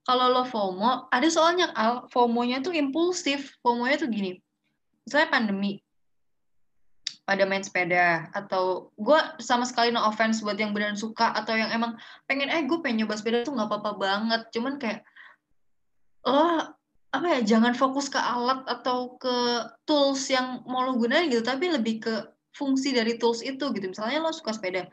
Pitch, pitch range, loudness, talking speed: 240 Hz, 215-275 Hz, -26 LUFS, 165 wpm